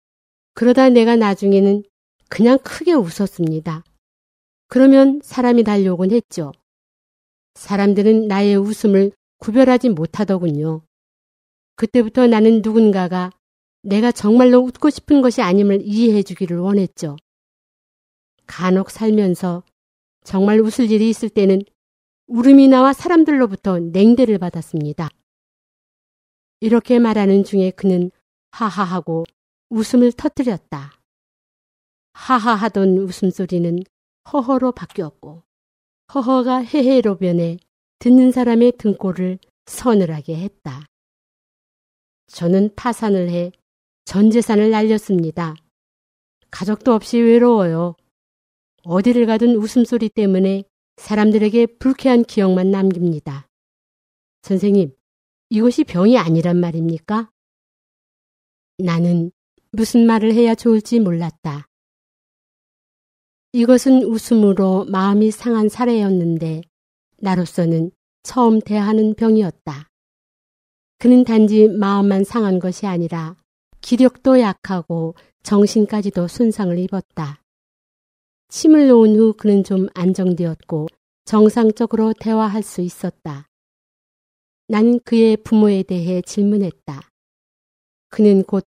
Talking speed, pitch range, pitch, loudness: 240 characters per minute, 180-230 Hz, 205 Hz, -15 LUFS